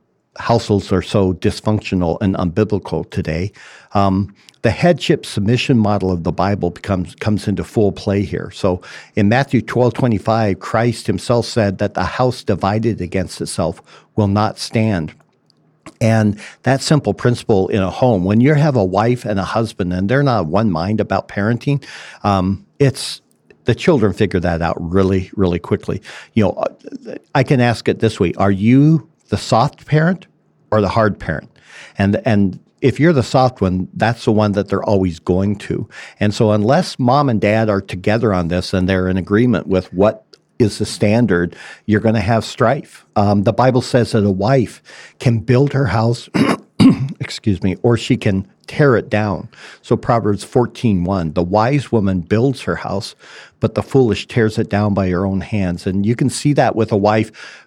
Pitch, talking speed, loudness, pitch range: 105 Hz, 180 wpm, -16 LUFS, 95-120 Hz